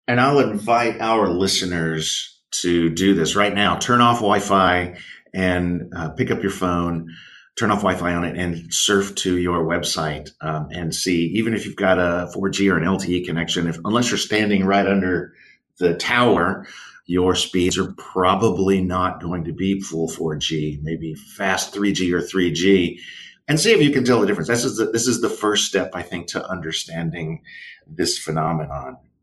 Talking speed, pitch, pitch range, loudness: 185 wpm, 90 Hz, 85-100 Hz, -20 LUFS